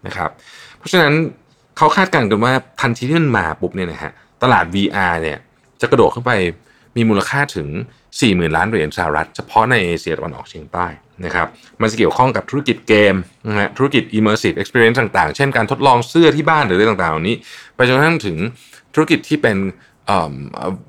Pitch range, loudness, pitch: 95-140 Hz, -16 LUFS, 115 Hz